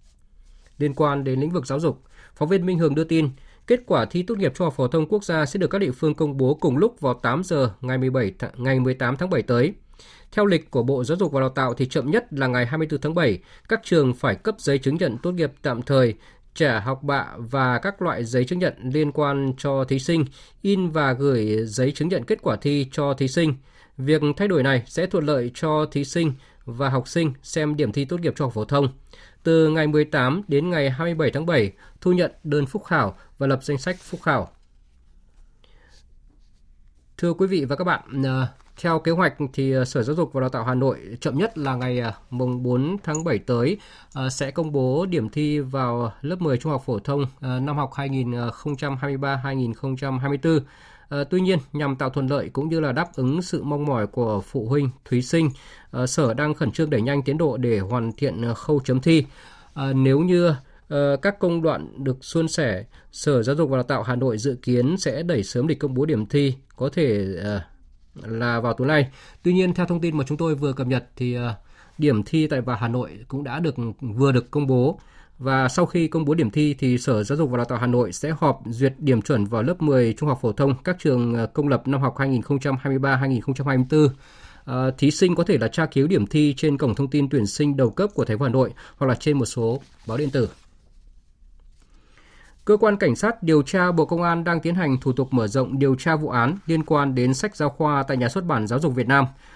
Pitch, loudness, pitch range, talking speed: 140 Hz, -22 LUFS, 125-155 Hz, 225 wpm